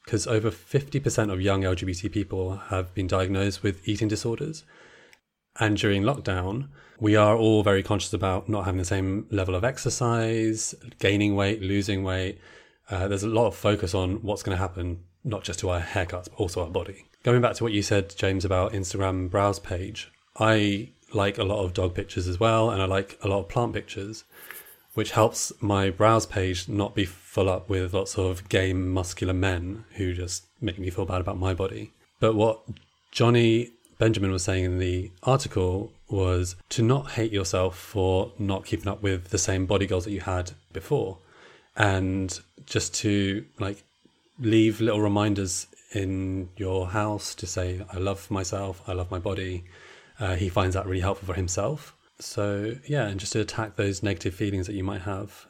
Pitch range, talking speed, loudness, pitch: 95-110 Hz, 185 wpm, -26 LUFS, 100 Hz